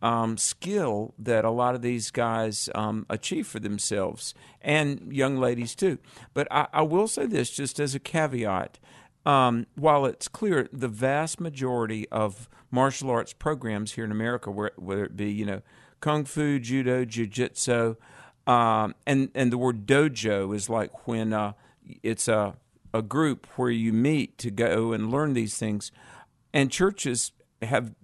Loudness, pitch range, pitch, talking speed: -27 LUFS, 110-135 Hz, 120 Hz, 165 wpm